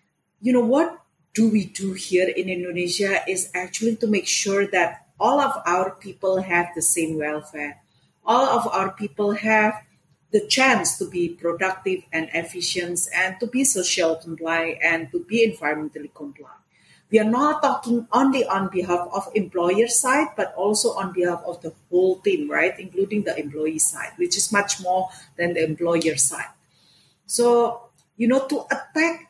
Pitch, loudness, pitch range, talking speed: 190 Hz, -21 LUFS, 170-225 Hz, 165 wpm